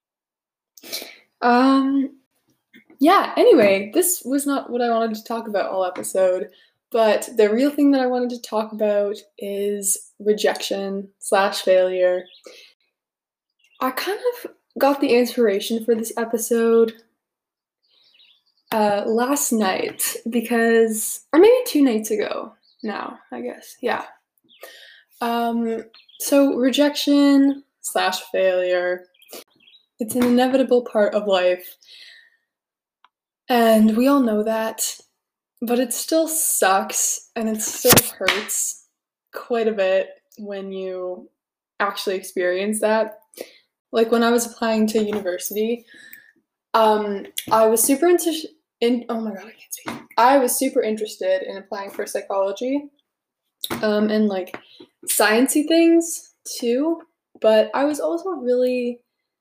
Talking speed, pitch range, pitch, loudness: 120 wpm, 210-280 Hz, 230 Hz, -20 LUFS